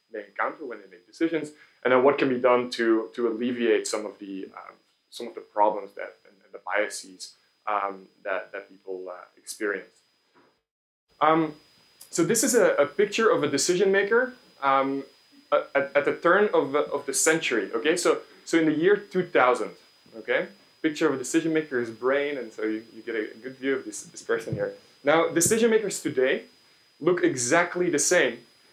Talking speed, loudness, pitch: 190 wpm, -25 LUFS, 160 Hz